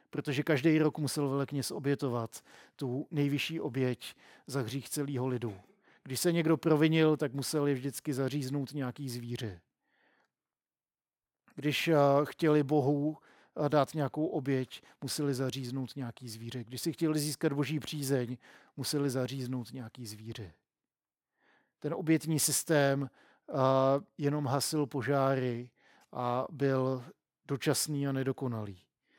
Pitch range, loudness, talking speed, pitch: 130-150 Hz, -32 LUFS, 115 wpm, 140 Hz